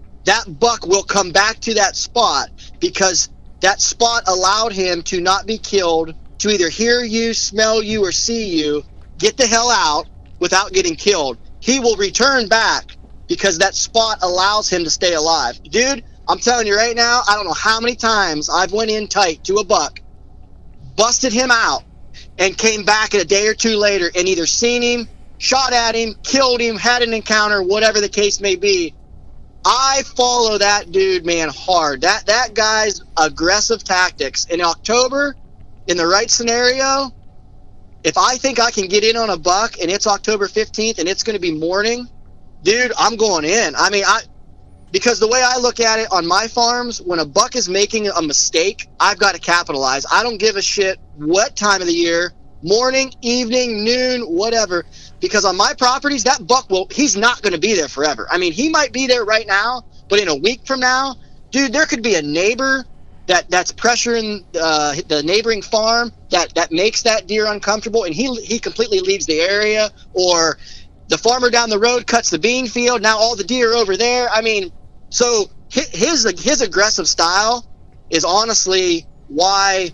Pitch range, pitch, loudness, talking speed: 195-245 Hz, 220 Hz, -15 LUFS, 190 wpm